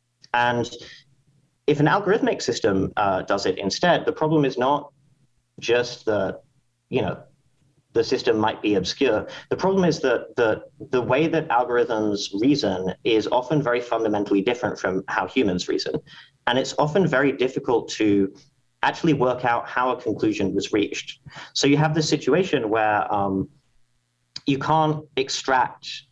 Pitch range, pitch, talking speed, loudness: 120-150 Hz, 130 Hz, 150 wpm, -22 LUFS